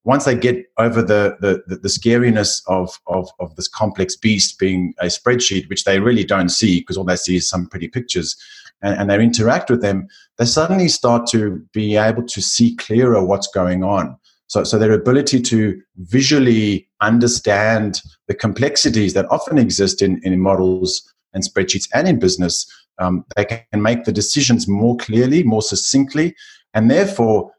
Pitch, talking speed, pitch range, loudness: 105 Hz, 175 wpm, 95-120 Hz, -16 LUFS